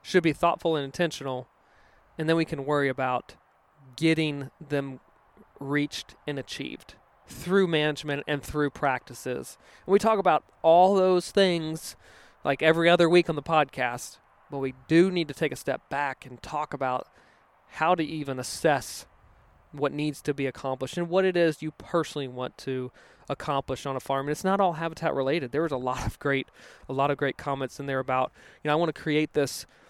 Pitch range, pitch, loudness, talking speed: 135-165 Hz, 145 Hz, -27 LUFS, 190 wpm